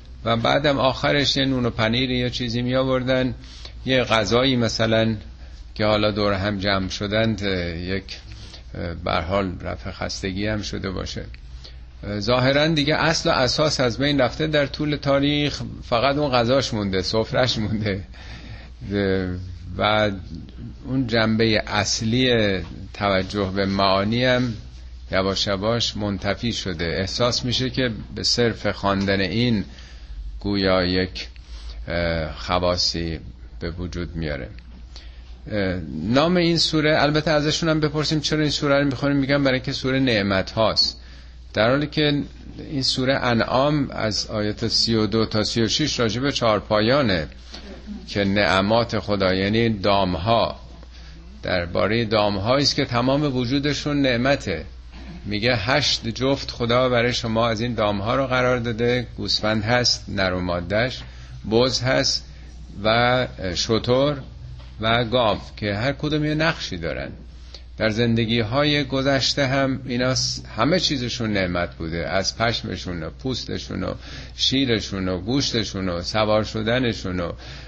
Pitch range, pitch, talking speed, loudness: 95-130 Hz, 110 Hz, 125 wpm, -21 LUFS